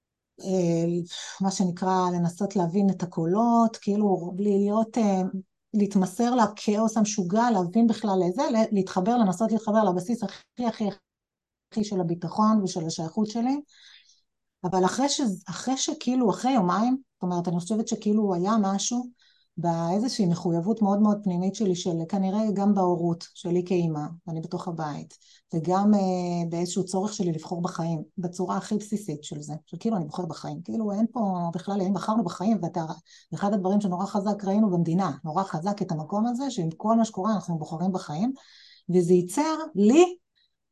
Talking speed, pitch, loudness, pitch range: 150 wpm, 195 Hz, -26 LUFS, 180-220 Hz